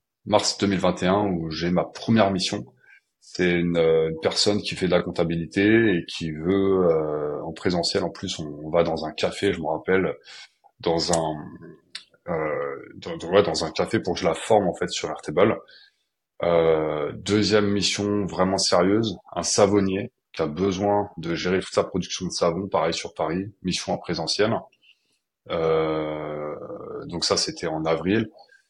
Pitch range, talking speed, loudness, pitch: 80-100 Hz, 165 wpm, -23 LUFS, 90 Hz